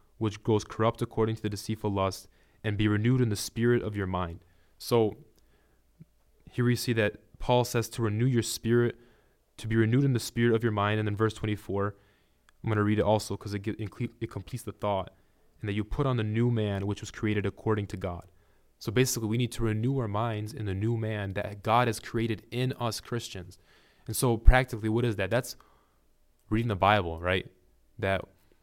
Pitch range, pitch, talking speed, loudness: 100-120 Hz, 110 Hz, 205 wpm, -29 LUFS